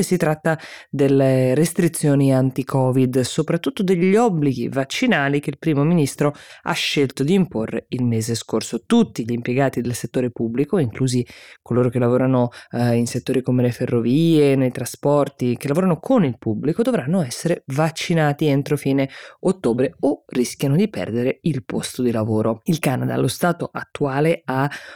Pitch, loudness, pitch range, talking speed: 135 Hz, -20 LUFS, 125-160 Hz, 150 wpm